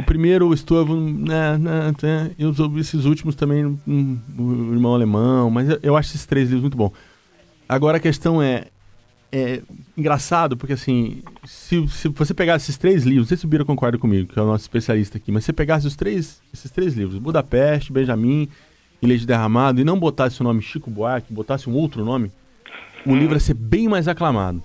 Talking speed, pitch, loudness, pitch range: 205 wpm, 140 Hz, -19 LUFS, 120-155 Hz